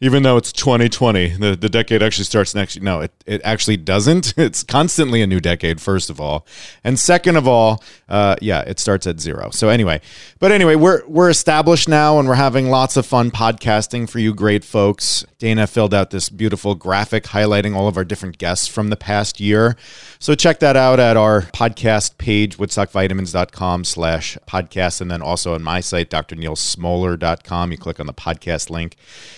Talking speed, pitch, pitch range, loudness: 190 wpm, 105 Hz, 90-120 Hz, -16 LUFS